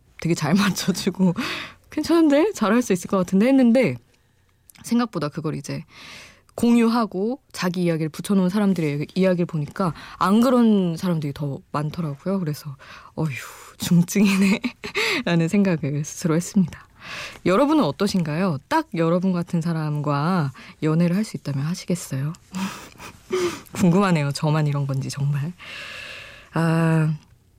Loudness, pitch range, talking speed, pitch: -22 LUFS, 150-205 Hz, 295 characters per minute, 175 Hz